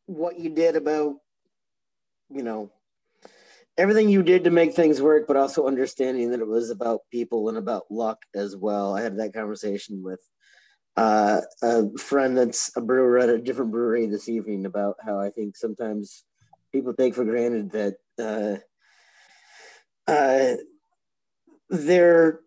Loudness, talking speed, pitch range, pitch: -23 LUFS, 150 wpm, 110-155 Hz, 120 Hz